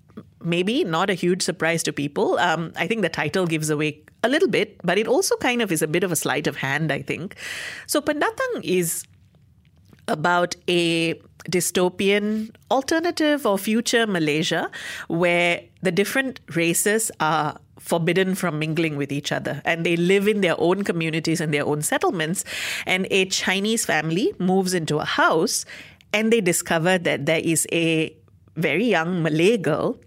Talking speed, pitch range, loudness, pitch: 165 wpm, 160-200 Hz, -22 LUFS, 175 Hz